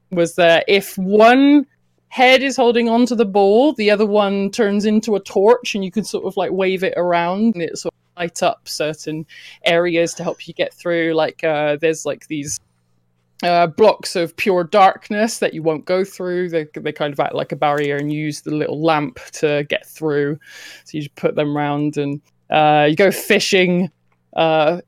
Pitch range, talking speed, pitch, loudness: 150-200 Hz, 200 wpm, 170 Hz, -17 LUFS